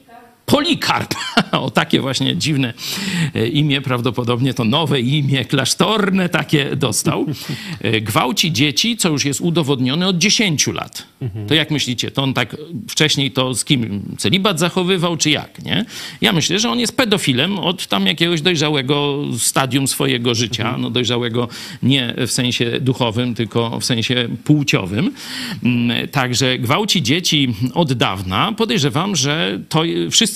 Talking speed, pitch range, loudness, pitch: 135 wpm, 125-175 Hz, -17 LUFS, 145 Hz